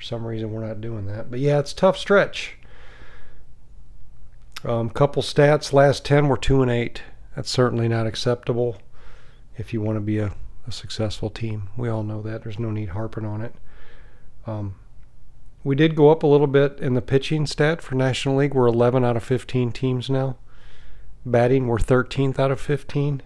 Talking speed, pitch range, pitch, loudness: 185 wpm, 115-135 Hz, 120 Hz, -22 LUFS